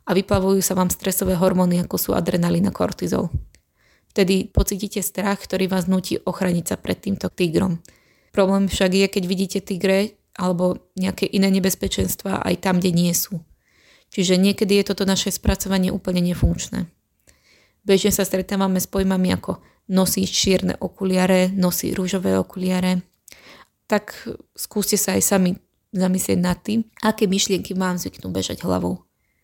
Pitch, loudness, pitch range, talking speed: 190 Hz, -21 LUFS, 180-195 Hz, 145 wpm